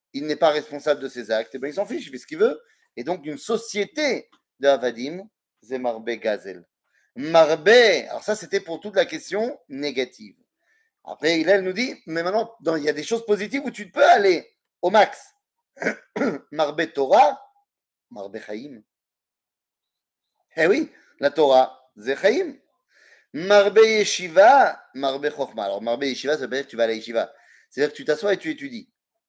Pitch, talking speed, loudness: 185 Hz, 170 wpm, -21 LUFS